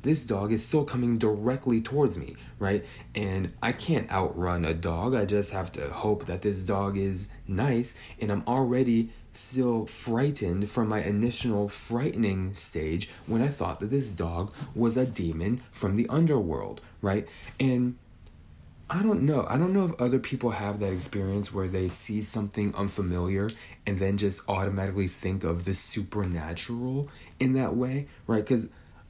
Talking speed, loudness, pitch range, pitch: 165 wpm, -28 LUFS, 95-125 Hz, 105 Hz